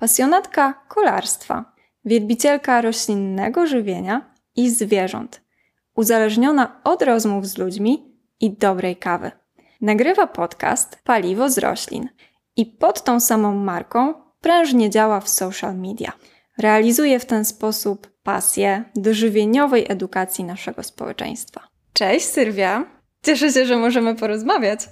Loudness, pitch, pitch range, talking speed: -19 LUFS, 225 Hz, 205-260 Hz, 115 wpm